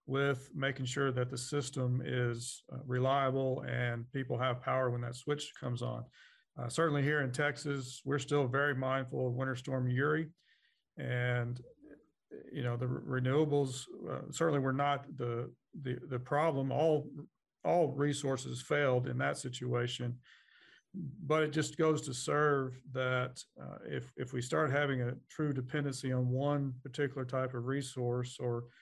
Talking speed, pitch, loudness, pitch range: 155 wpm, 130 Hz, -35 LUFS, 125-145 Hz